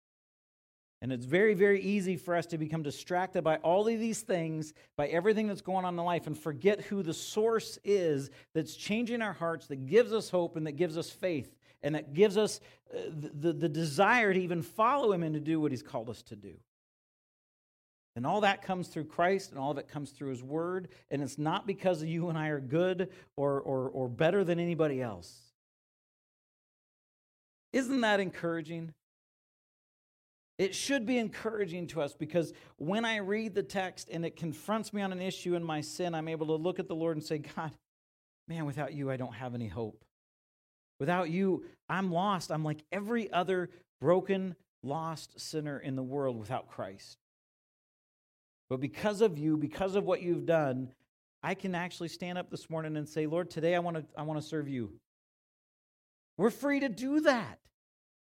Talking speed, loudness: 190 wpm, -33 LUFS